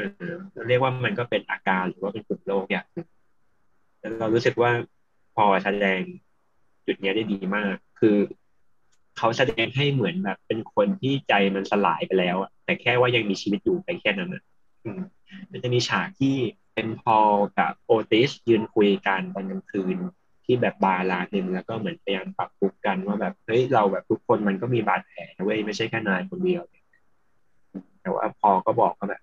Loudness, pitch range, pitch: -24 LUFS, 100-135 Hz, 110 Hz